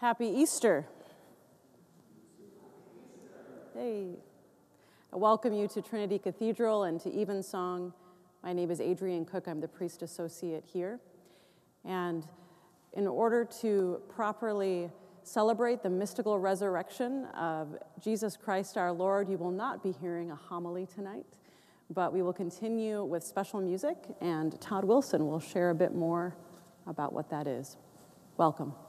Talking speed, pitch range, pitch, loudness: 135 wpm, 175-210 Hz, 185 Hz, -34 LUFS